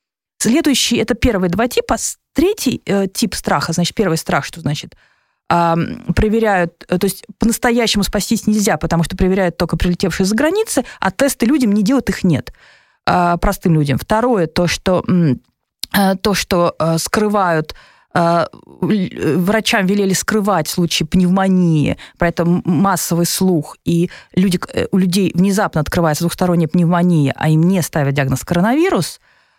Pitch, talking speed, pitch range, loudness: 185 Hz, 140 wpm, 170-210 Hz, -16 LUFS